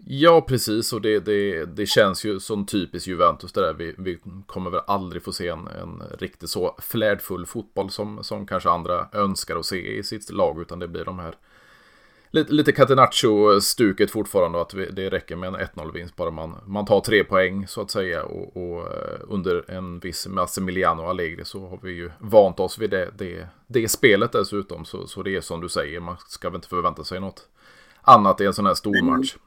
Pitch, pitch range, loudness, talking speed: 95 Hz, 90-105 Hz, -22 LUFS, 210 wpm